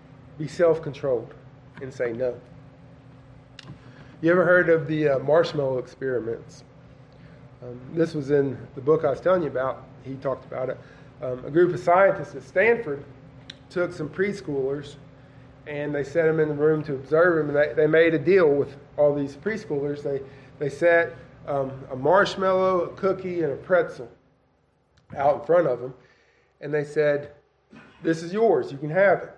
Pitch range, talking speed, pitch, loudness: 135-165 Hz, 170 wpm, 145 Hz, -23 LUFS